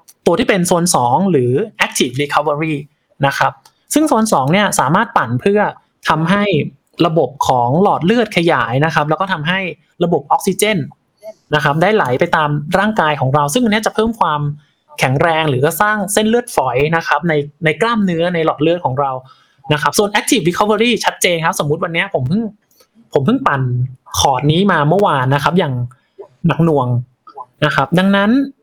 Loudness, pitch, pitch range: -15 LUFS, 165 Hz, 145-200 Hz